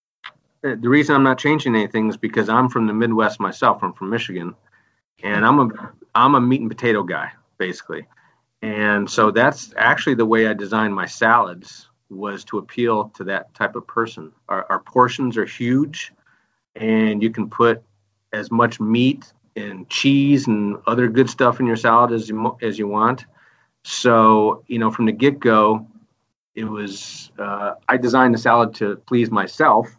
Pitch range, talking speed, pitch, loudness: 110-125 Hz, 175 wpm, 115 Hz, -18 LUFS